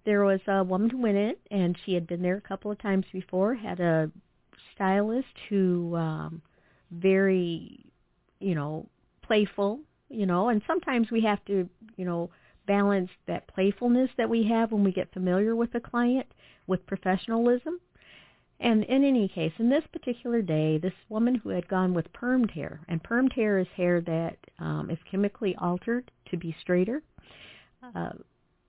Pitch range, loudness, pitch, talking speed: 180-230 Hz, -28 LUFS, 195 Hz, 170 wpm